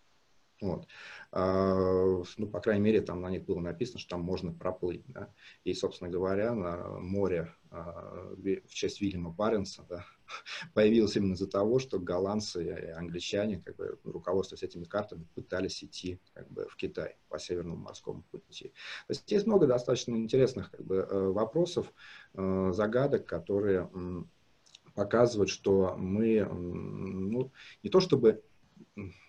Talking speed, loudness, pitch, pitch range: 135 wpm, -32 LUFS, 95 Hz, 90-110 Hz